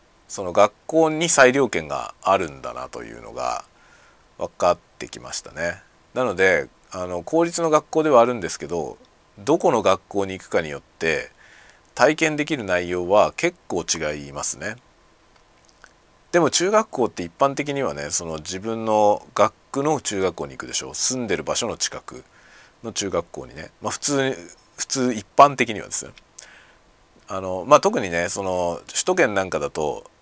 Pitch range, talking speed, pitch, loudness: 90-150 Hz, 305 characters per minute, 115 Hz, -21 LUFS